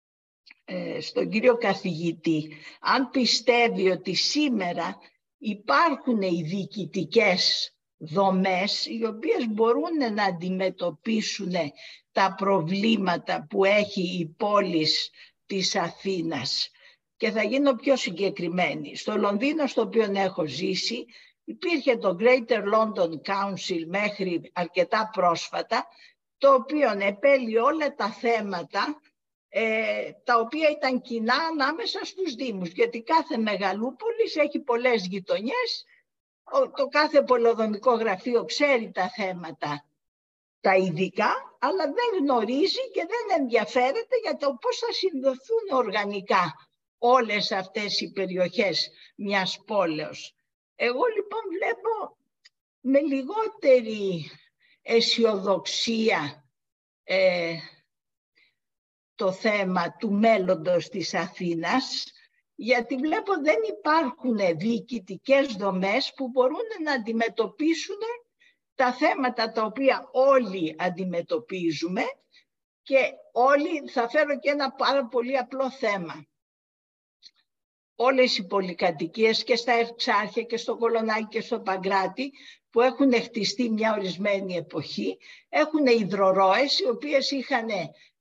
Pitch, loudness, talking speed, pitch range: 230 Hz, -25 LUFS, 105 wpm, 190-275 Hz